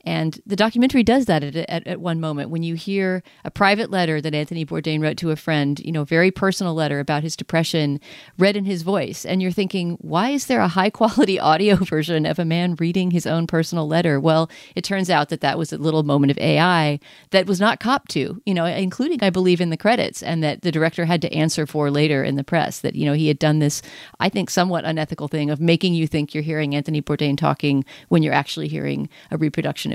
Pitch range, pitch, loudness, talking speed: 155-185 Hz, 165 Hz, -20 LUFS, 235 wpm